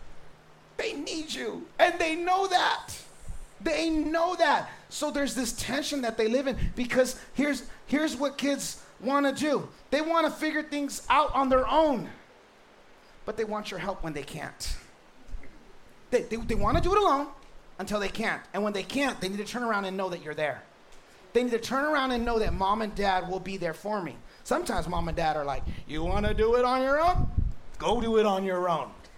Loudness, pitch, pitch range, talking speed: -28 LUFS, 245 Hz, 195-290 Hz, 215 wpm